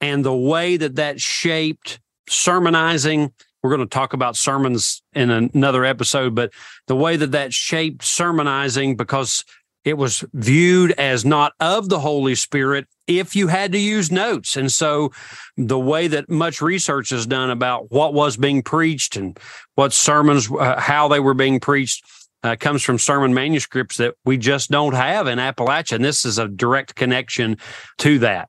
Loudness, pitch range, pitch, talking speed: -18 LUFS, 130-155 Hz, 140 Hz, 175 wpm